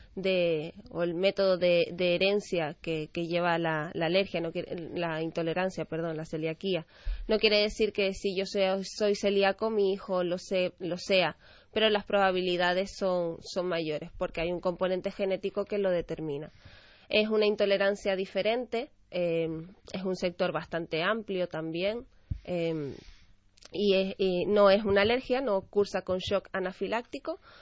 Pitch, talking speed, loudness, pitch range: 185 Hz, 155 wpm, -29 LUFS, 170-200 Hz